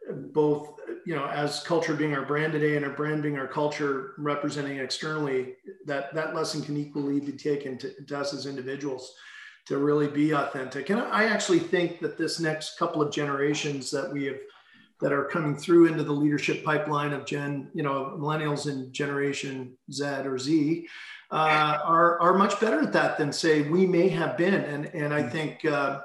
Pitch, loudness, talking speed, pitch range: 150 Hz, -27 LUFS, 190 wpm, 140-155 Hz